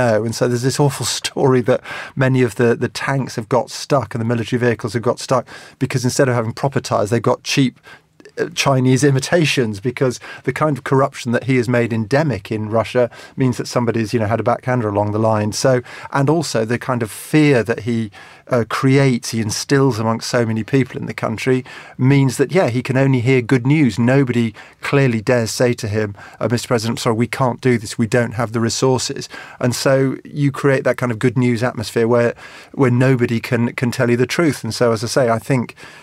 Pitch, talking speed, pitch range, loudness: 125 Hz, 215 wpm, 115-135 Hz, -17 LUFS